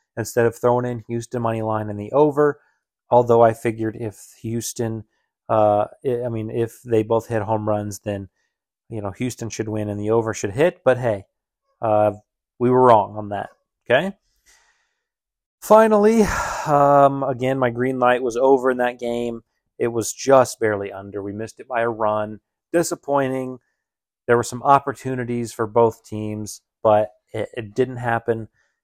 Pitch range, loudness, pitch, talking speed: 110-130 Hz, -20 LUFS, 115 Hz, 165 wpm